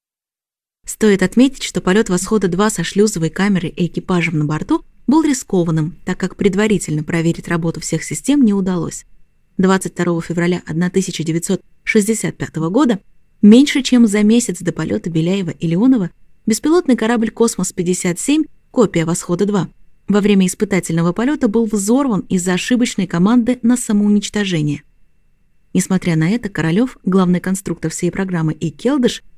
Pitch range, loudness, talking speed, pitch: 170-220 Hz, -16 LUFS, 130 wpm, 190 Hz